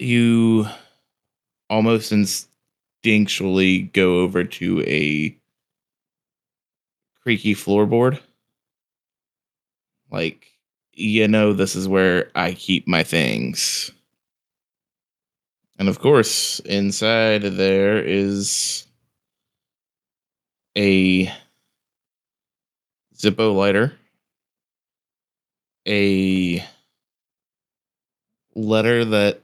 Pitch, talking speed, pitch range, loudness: 100 Hz, 65 wpm, 95-110 Hz, -19 LUFS